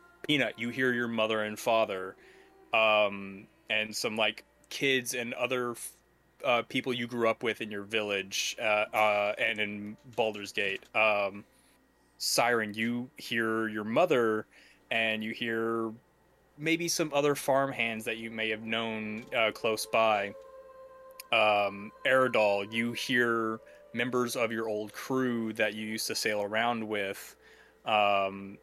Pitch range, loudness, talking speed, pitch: 105-125 Hz, -30 LUFS, 140 wpm, 115 Hz